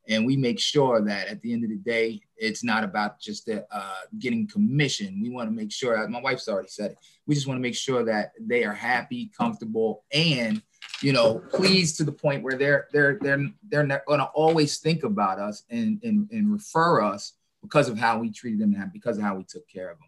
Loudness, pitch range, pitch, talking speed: -25 LUFS, 135-215 Hz, 160 Hz, 235 wpm